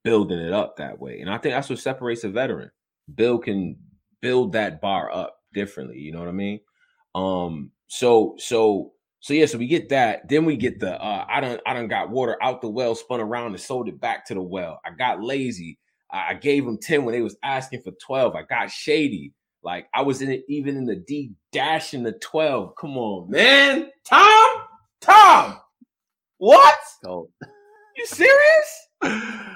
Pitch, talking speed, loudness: 135 Hz, 195 wpm, -19 LUFS